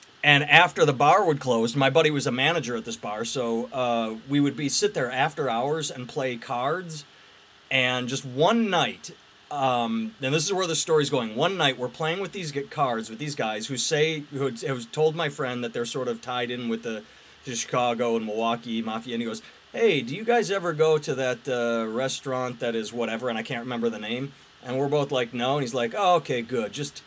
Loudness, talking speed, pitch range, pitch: -25 LUFS, 230 wpm, 120-155 Hz, 130 Hz